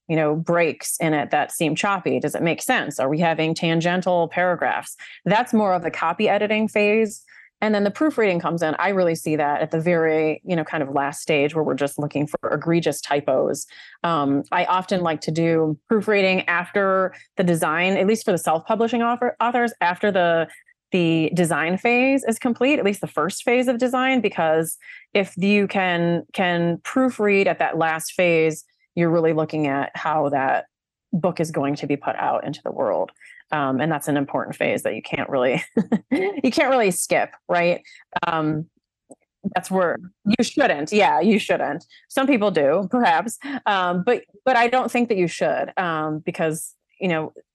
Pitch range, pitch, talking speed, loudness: 160-210 Hz, 175 Hz, 185 wpm, -21 LUFS